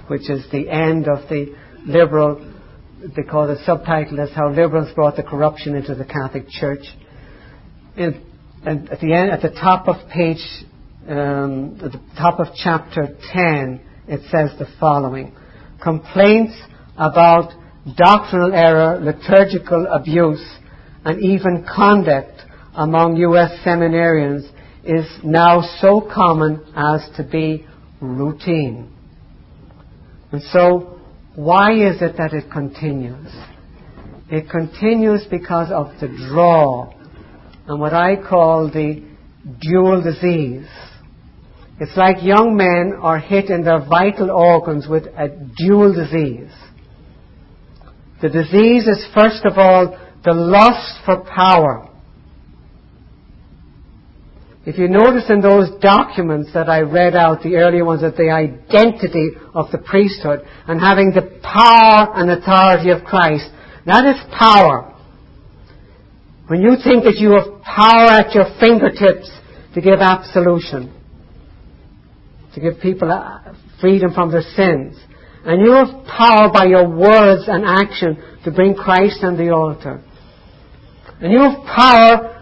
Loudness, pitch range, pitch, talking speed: -13 LUFS, 150-190 Hz, 170 Hz, 125 wpm